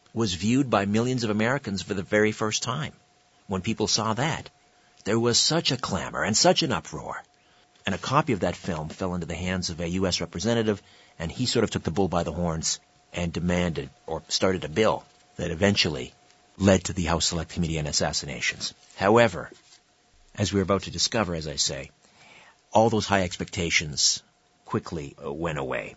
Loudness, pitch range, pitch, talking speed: -25 LUFS, 85-110 Hz, 100 Hz, 185 wpm